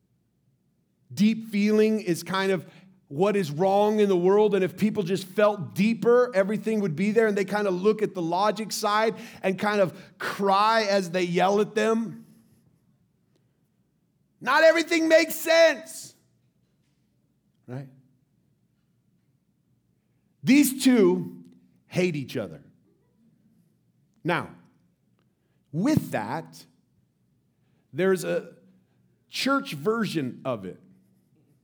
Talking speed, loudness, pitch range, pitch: 110 wpm, -24 LUFS, 175-220 Hz, 200 Hz